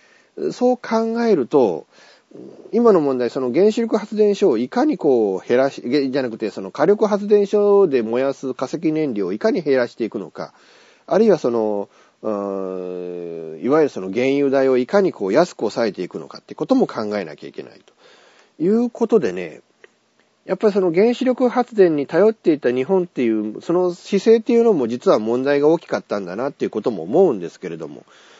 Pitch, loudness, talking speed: 175 Hz, -19 LUFS, 365 characters per minute